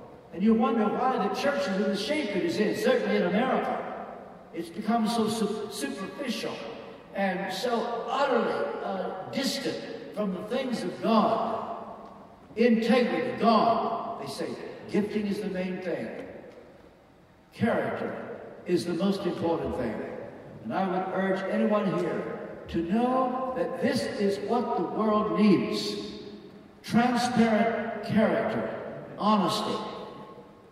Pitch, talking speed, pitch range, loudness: 215 Hz, 125 wpm, 200-235 Hz, -28 LUFS